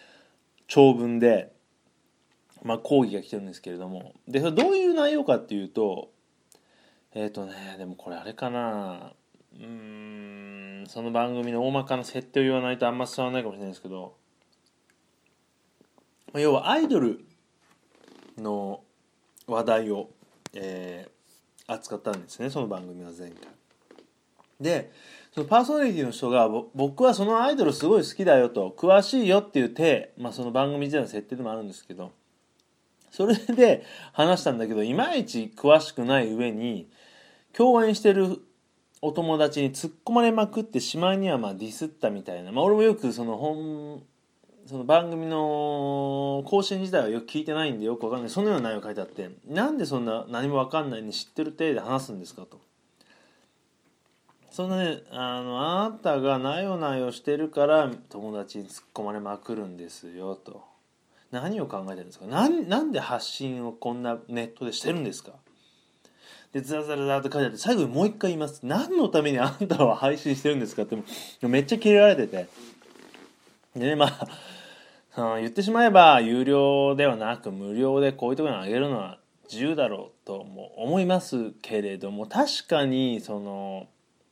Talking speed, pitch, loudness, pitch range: 335 characters per minute, 130 Hz, -25 LUFS, 110-155 Hz